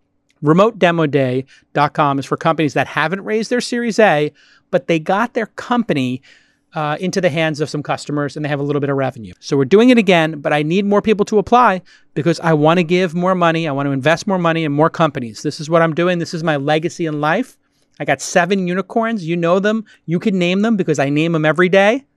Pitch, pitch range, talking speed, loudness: 165 Hz, 150-195 Hz, 235 wpm, -16 LUFS